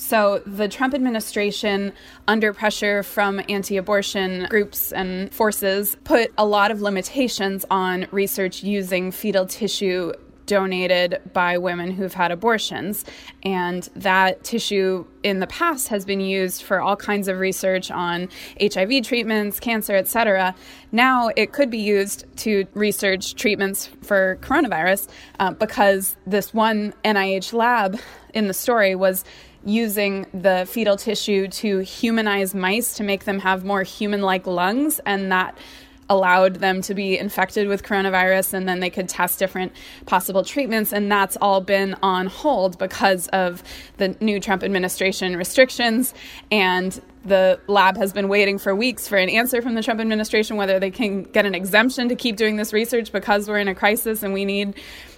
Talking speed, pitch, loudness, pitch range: 160 wpm, 200 Hz, -20 LUFS, 190-215 Hz